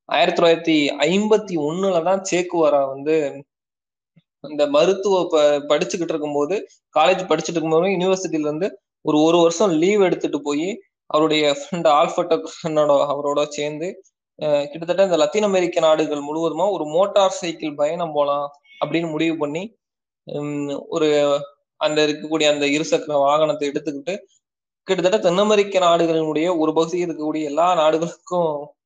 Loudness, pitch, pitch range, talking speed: -19 LUFS, 155 Hz, 145-175 Hz, 120 wpm